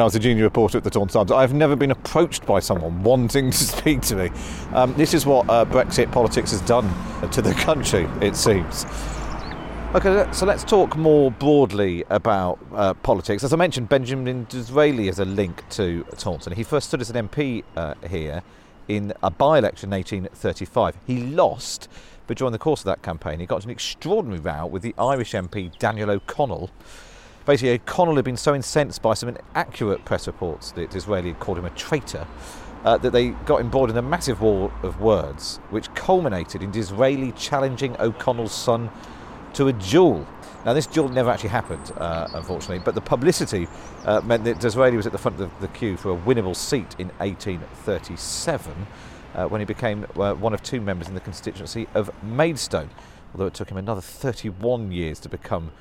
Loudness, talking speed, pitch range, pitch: -22 LUFS, 190 wpm, 100-130 Hz, 115 Hz